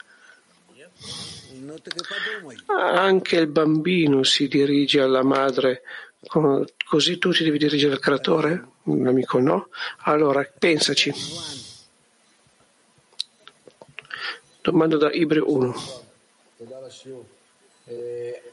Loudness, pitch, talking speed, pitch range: -21 LUFS, 150 Hz, 75 wpm, 135-175 Hz